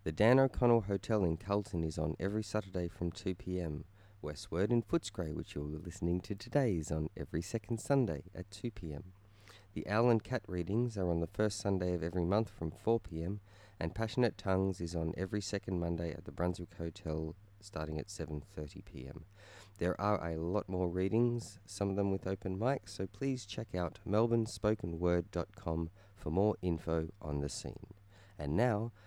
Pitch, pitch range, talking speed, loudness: 95 Hz, 85-105 Hz, 170 wpm, -36 LUFS